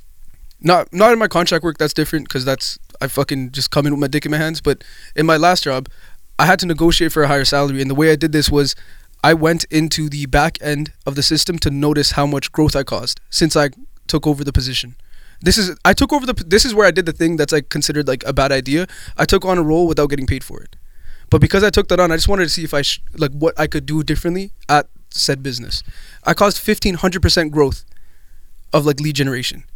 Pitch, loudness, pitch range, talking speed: 150 Hz, -16 LUFS, 140-165 Hz, 250 wpm